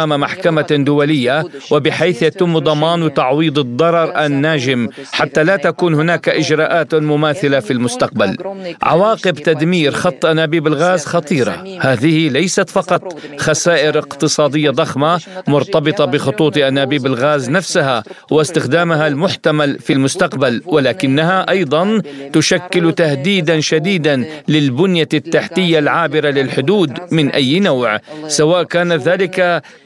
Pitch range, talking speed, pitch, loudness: 145-170 Hz, 105 wpm, 155 Hz, -14 LUFS